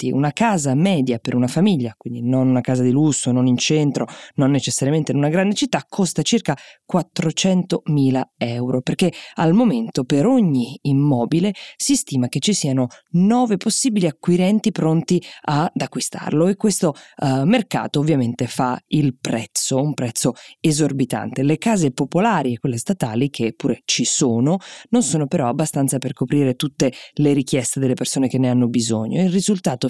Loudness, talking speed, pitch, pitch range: -19 LUFS, 165 wpm, 145 Hz, 130-180 Hz